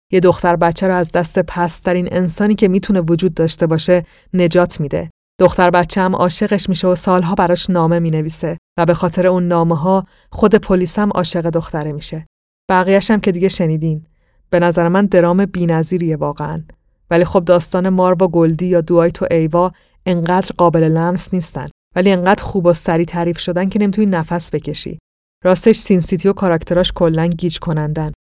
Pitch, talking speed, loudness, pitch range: 175 Hz, 170 wpm, -15 LUFS, 170-185 Hz